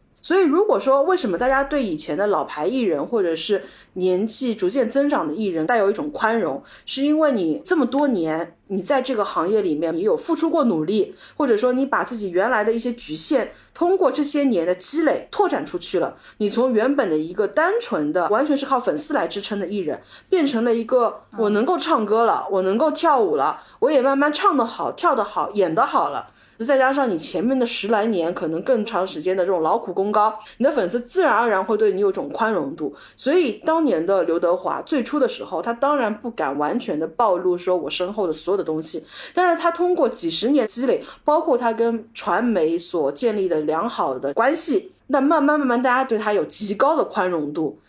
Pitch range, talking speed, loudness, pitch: 195-300 Hz, 315 characters per minute, -21 LUFS, 245 Hz